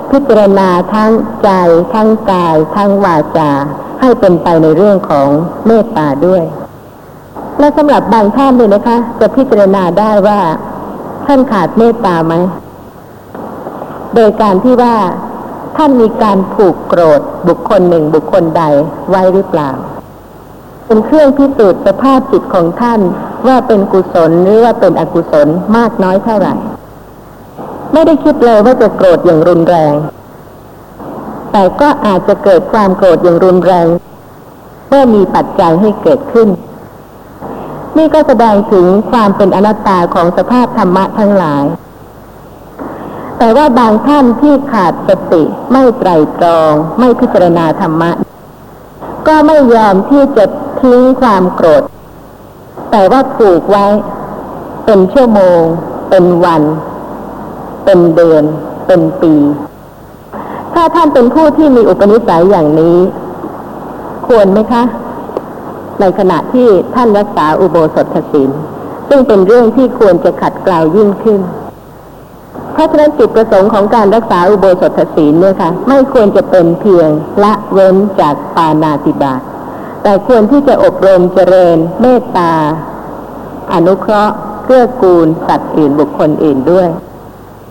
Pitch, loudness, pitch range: 200 Hz, -8 LUFS, 170-235 Hz